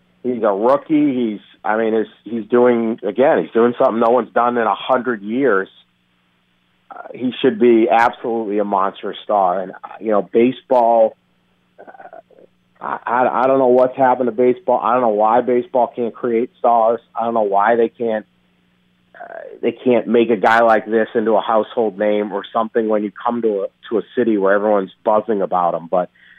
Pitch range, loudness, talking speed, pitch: 100-120 Hz, -17 LUFS, 190 wpm, 115 Hz